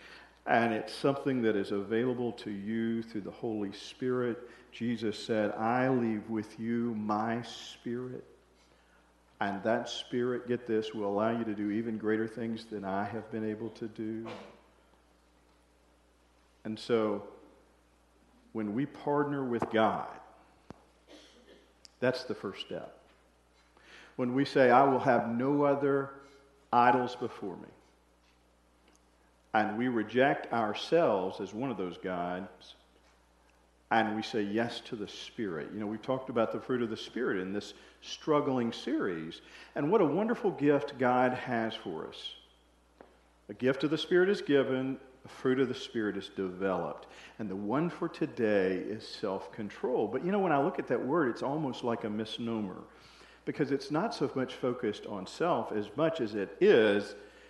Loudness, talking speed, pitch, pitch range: -32 LUFS, 155 wpm, 110 Hz, 95-125 Hz